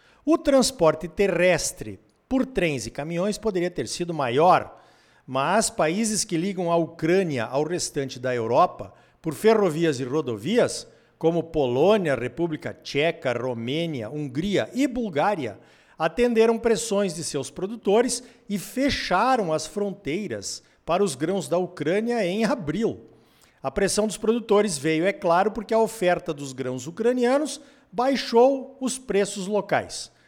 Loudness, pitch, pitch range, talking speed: -24 LUFS, 180 Hz, 155-225 Hz, 130 wpm